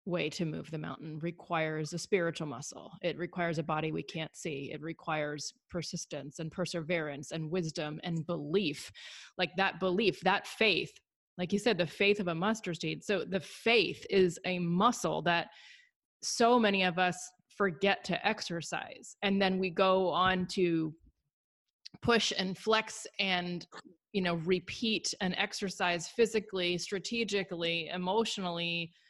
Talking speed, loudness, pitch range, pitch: 145 wpm, -32 LUFS, 170-200 Hz, 180 Hz